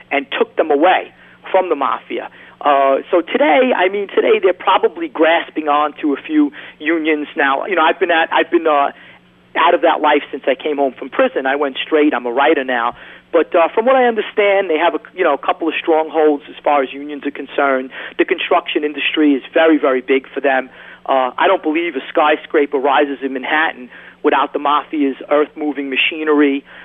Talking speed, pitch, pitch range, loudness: 205 wpm, 150 Hz, 140-165 Hz, -15 LUFS